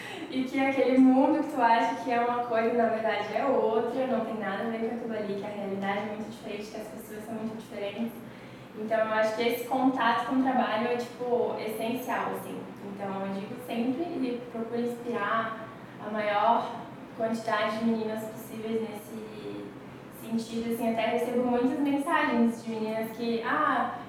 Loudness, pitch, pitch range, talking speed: -29 LUFS, 230 Hz, 220-240 Hz, 180 wpm